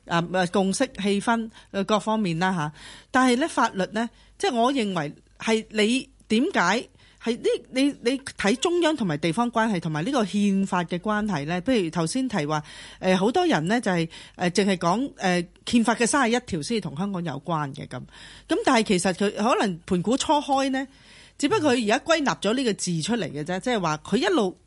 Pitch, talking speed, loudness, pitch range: 210 Hz, 275 characters per minute, -24 LUFS, 180-245 Hz